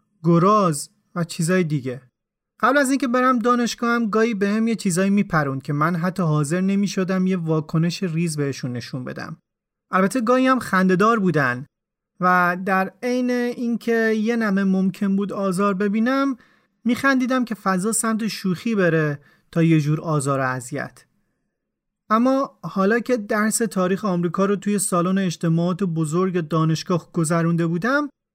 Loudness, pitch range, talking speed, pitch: -21 LUFS, 170-225 Hz, 145 wpm, 190 Hz